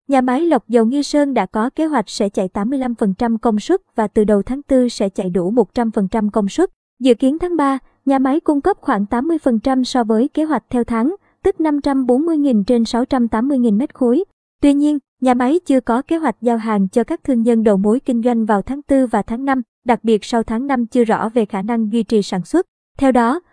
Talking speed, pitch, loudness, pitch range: 225 wpm, 245 Hz, -17 LUFS, 225-275 Hz